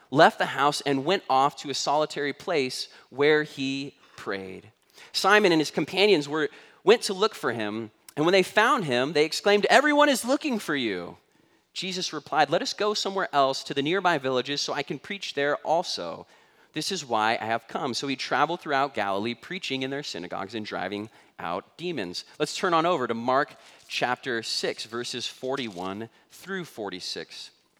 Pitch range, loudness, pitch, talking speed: 120-180 Hz, -26 LUFS, 145 Hz, 180 wpm